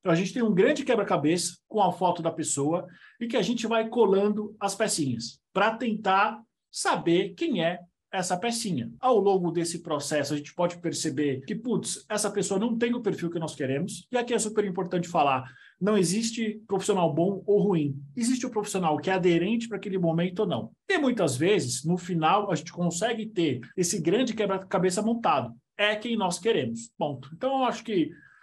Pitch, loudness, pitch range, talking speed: 195 Hz, -27 LUFS, 170-220 Hz, 190 wpm